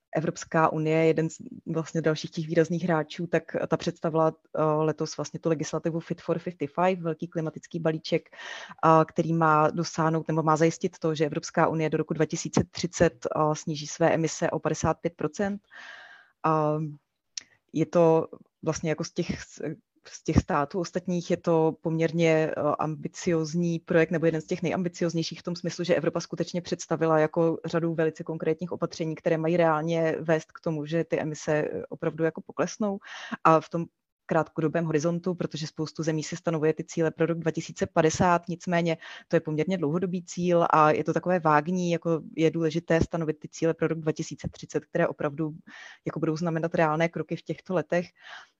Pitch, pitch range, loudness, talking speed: 165 Hz, 160-170 Hz, -27 LUFS, 165 wpm